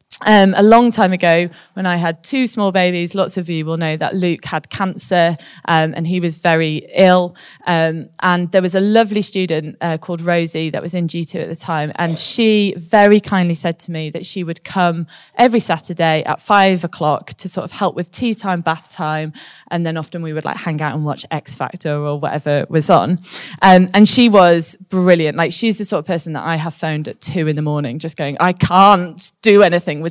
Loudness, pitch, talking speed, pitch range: -15 LUFS, 175 Hz, 220 wpm, 160-190 Hz